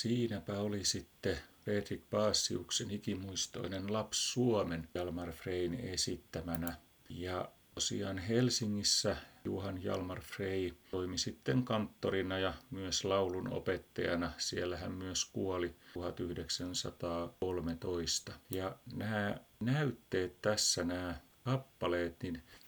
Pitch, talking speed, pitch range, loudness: 95 Hz, 95 wpm, 90-105 Hz, -37 LUFS